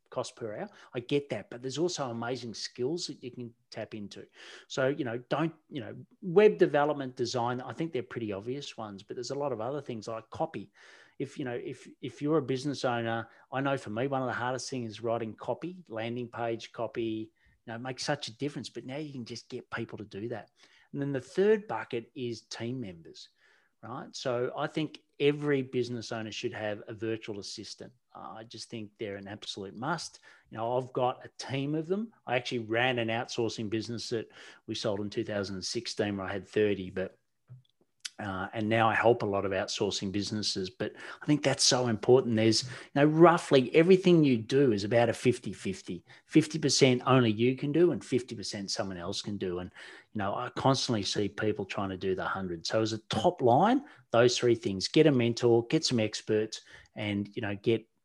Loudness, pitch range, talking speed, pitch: -30 LUFS, 110-135 Hz, 210 wpm, 120 Hz